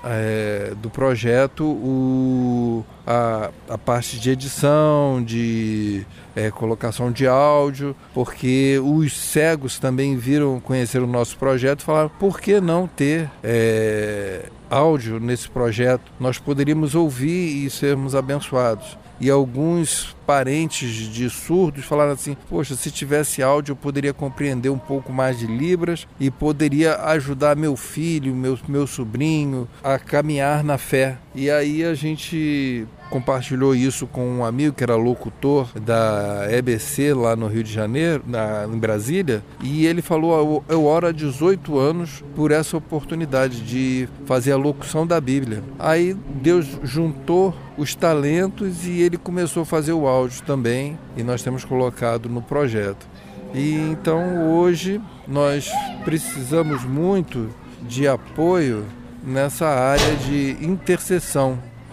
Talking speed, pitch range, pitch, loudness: 135 wpm, 125-155 Hz, 140 Hz, -21 LUFS